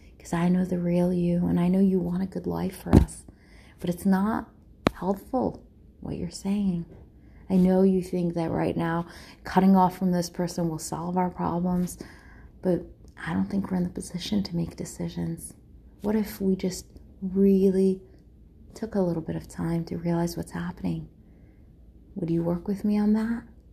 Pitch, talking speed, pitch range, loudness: 180 Hz, 180 wpm, 170-190 Hz, -27 LUFS